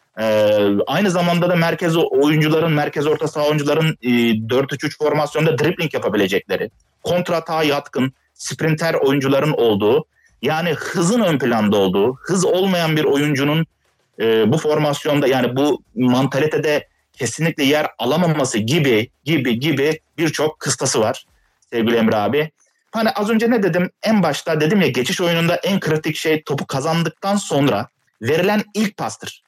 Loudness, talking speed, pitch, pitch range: -18 LUFS, 135 wpm, 155 Hz, 140-170 Hz